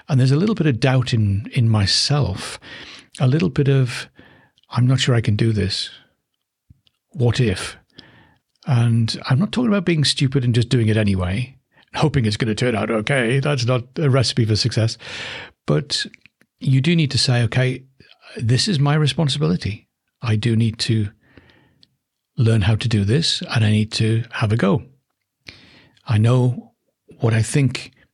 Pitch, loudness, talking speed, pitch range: 125 Hz, -19 LUFS, 170 wpm, 110-140 Hz